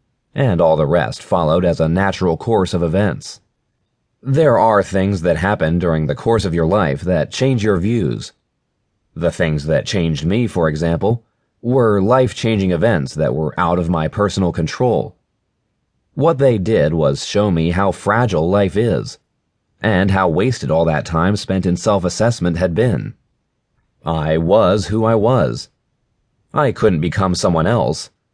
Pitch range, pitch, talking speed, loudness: 85-110 Hz, 95 Hz, 155 wpm, -16 LUFS